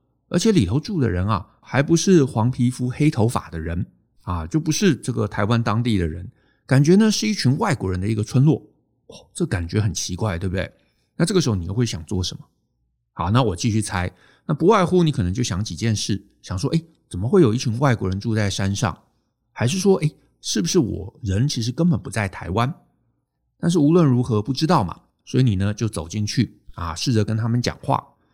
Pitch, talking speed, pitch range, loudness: 115 Hz, 305 characters per minute, 100-145 Hz, -21 LUFS